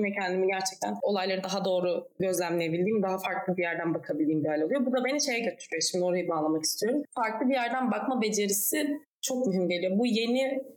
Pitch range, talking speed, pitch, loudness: 180-255 Hz, 190 wpm, 190 Hz, -28 LUFS